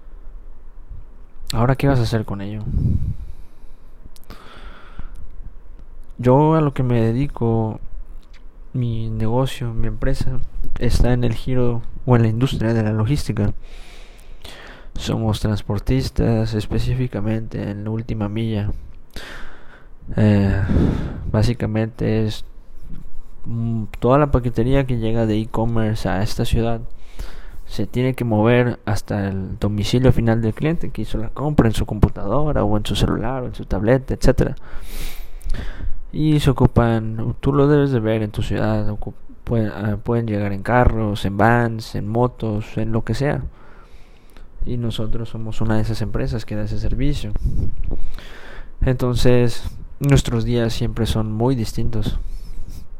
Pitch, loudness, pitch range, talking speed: 110 Hz, -20 LUFS, 105-120 Hz, 130 wpm